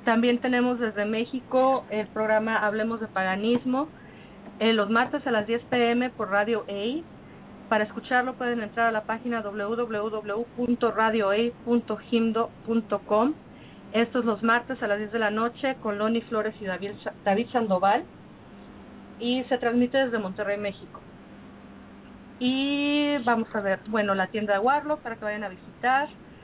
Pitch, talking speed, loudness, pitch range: 225 Hz, 145 wpm, -26 LUFS, 210-245 Hz